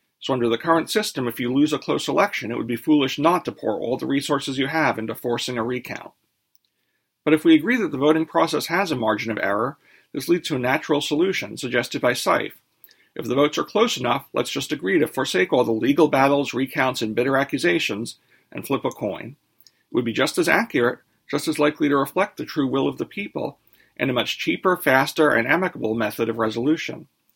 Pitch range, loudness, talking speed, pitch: 125-155 Hz, -22 LUFS, 215 wpm, 140 Hz